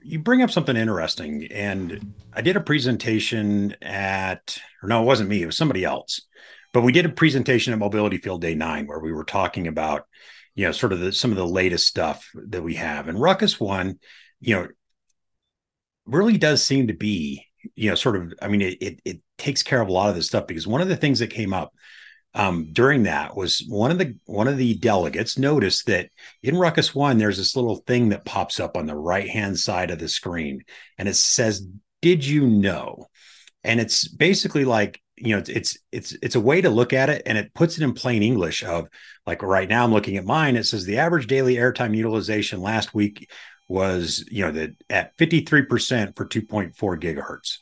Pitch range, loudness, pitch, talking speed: 95-135 Hz, -22 LUFS, 110 Hz, 215 wpm